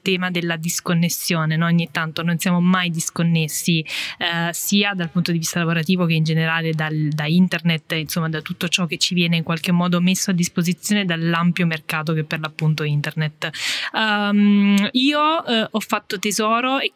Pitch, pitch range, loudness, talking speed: 175 Hz, 165-190 Hz, -19 LUFS, 175 wpm